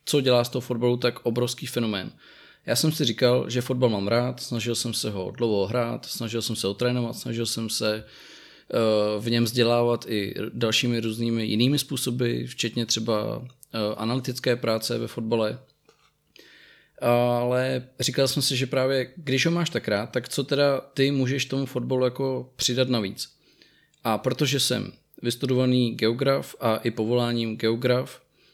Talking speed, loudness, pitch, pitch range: 155 wpm, -25 LUFS, 120 Hz, 115-130 Hz